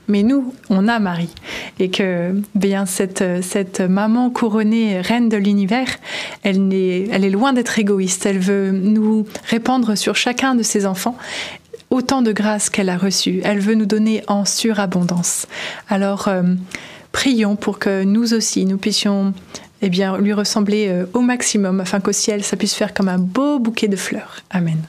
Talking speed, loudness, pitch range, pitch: 170 wpm, -17 LUFS, 195-220 Hz, 205 Hz